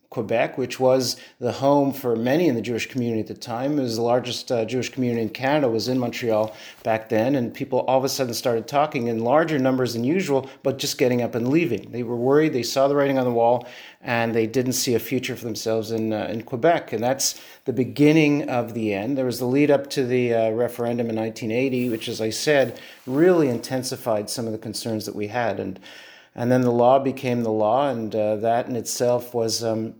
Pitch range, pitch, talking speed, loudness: 115-130 Hz, 120 Hz, 230 wpm, -22 LUFS